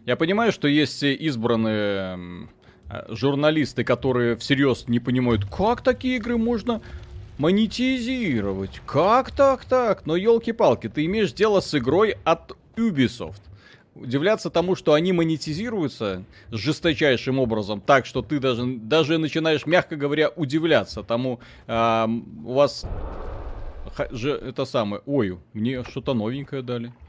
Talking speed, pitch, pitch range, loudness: 120 wpm, 140 Hz, 115-165 Hz, -23 LUFS